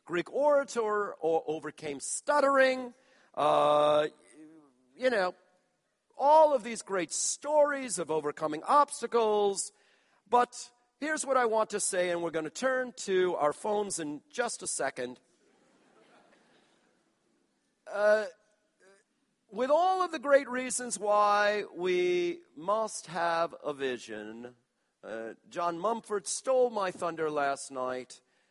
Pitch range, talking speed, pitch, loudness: 160-255 Hz, 120 wpm, 205 Hz, -29 LUFS